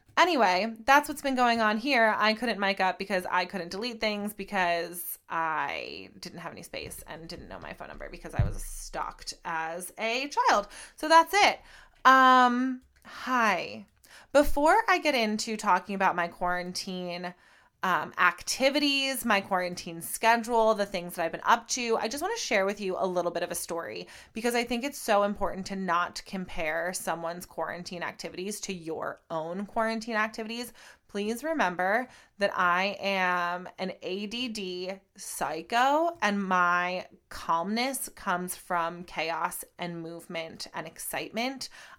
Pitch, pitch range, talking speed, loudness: 195 Hz, 175-235 Hz, 155 wpm, -28 LUFS